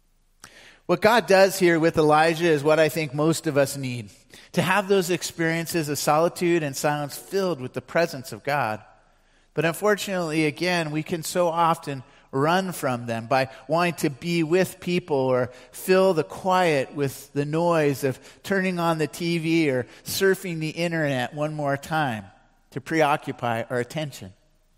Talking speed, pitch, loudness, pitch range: 160 wpm, 155 Hz, -23 LUFS, 135-170 Hz